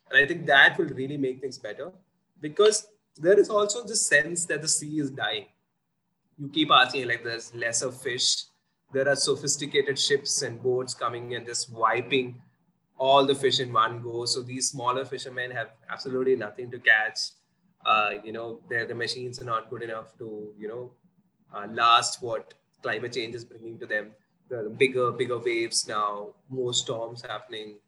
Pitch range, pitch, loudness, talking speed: 115-180 Hz, 130 Hz, -25 LUFS, 175 wpm